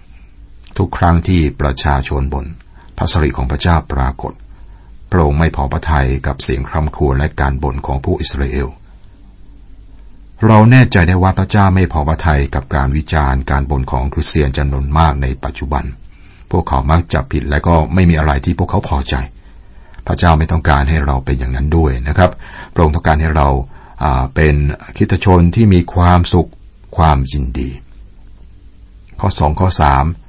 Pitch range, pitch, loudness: 70-90 Hz, 80 Hz, -14 LUFS